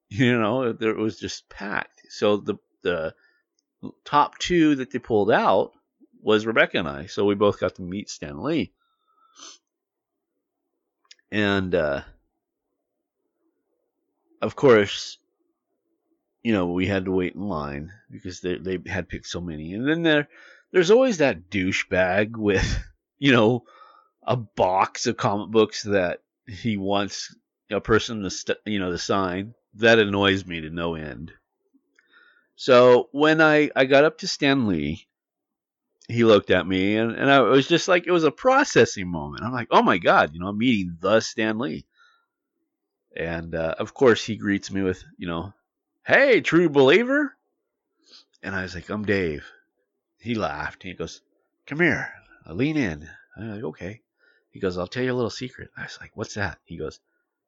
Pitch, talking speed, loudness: 115 Hz, 170 wpm, -22 LUFS